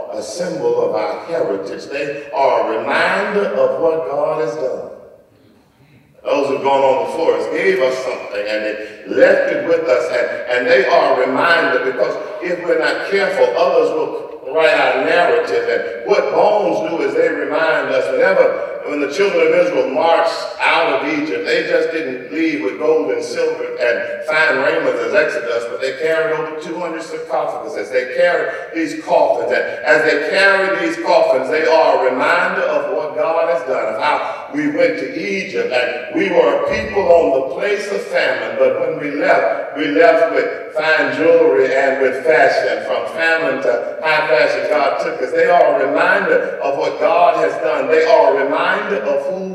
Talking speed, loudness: 185 wpm, -16 LUFS